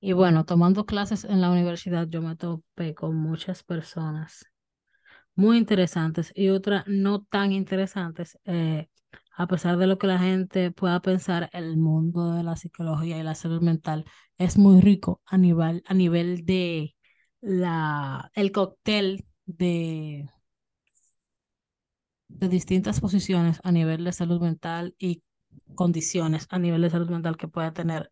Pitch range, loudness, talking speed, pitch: 165-190 Hz, -25 LUFS, 145 wpm, 175 Hz